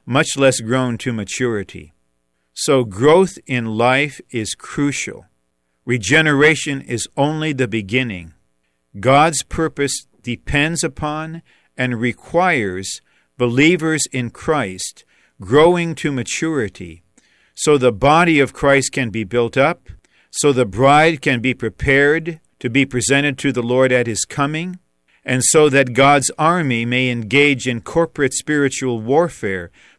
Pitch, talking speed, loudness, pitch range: 130 Hz, 125 wpm, -16 LUFS, 115-150 Hz